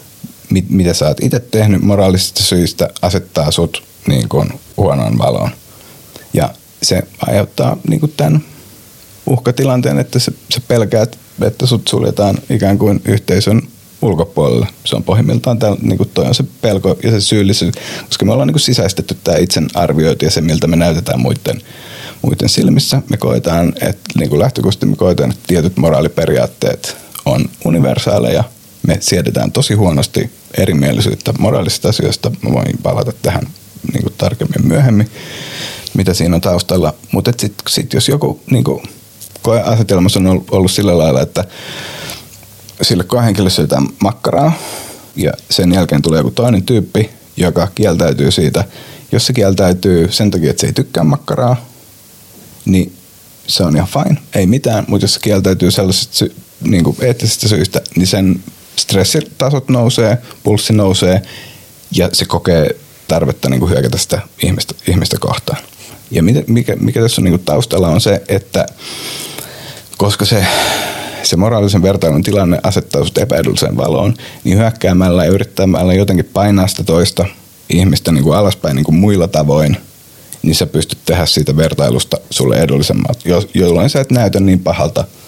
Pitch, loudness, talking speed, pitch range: 100 Hz, -13 LUFS, 145 wpm, 90-120 Hz